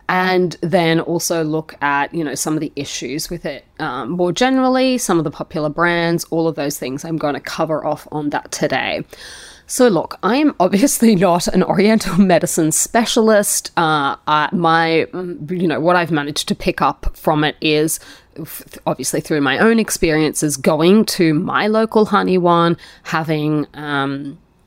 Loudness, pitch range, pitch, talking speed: -16 LUFS, 155-190 Hz, 170 Hz, 165 wpm